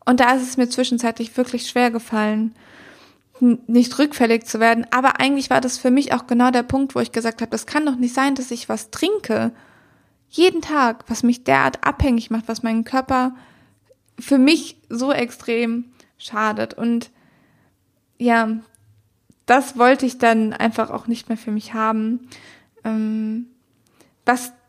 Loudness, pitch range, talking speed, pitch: -19 LUFS, 230-255 Hz, 160 wpm, 240 Hz